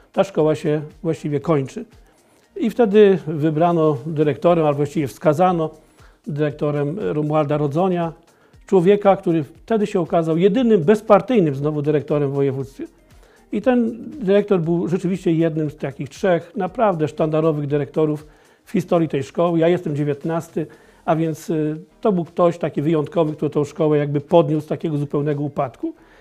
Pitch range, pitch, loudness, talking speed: 150-185 Hz, 160 Hz, -19 LUFS, 140 wpm